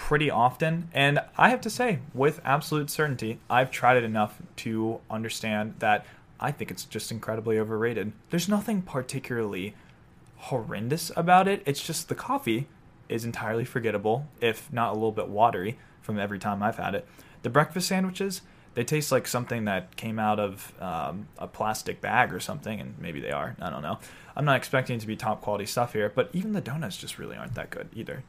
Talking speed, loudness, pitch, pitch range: 195 wpm, -28 LUFS, 125 Hz, 110-155 Hz